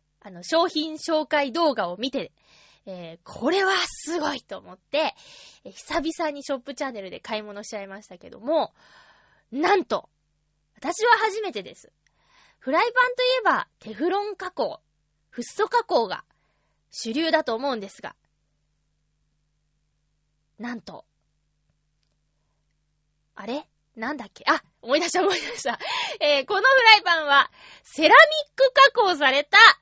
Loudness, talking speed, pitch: -21 LUFS, 265 characters per minute, 275 Hz